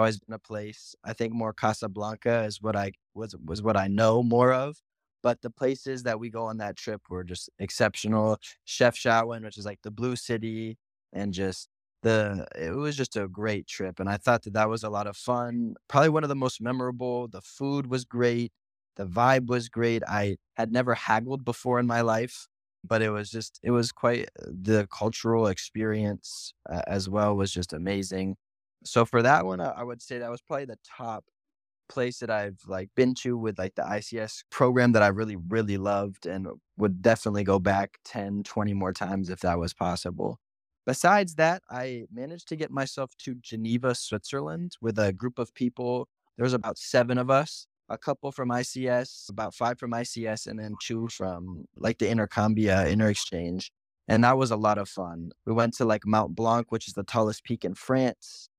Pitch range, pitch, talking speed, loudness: 100-125 Hz, 110 Hz, 200 wpm, -28 LUFS